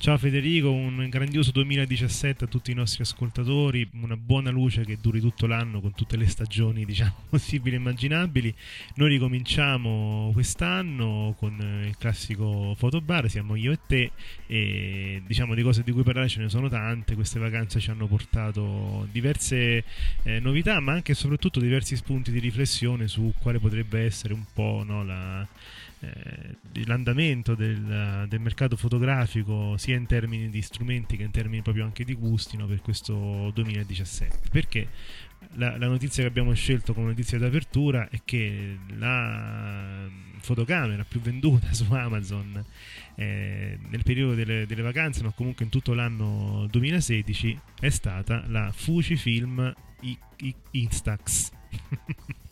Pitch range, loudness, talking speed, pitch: 105-125 Hz, -27 LUFS, 145 wpm, 115 Hz